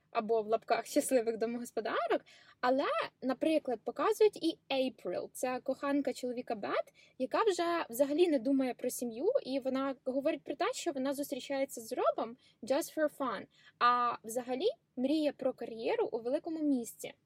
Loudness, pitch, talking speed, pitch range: -34 LUFS, 265 Hz, 145 wpm, 245-295 Hz